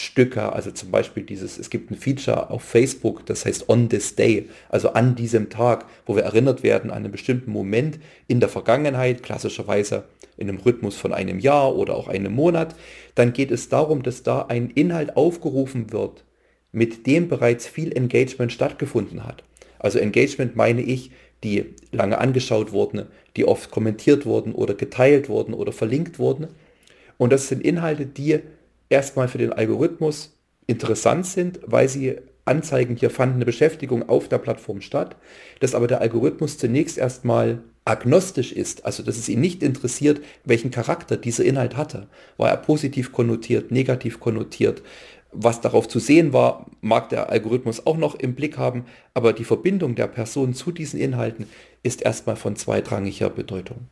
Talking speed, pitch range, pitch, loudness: 165 wpm, 115-145 Hz, 125 Hz, -22 LUFS